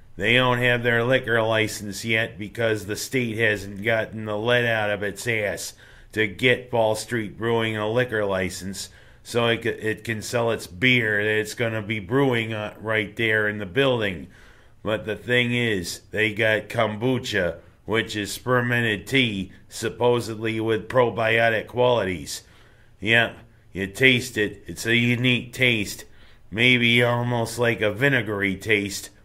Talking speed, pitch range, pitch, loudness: 150 wpm, 105-120 Hz, 110 Hz, -22 LUFS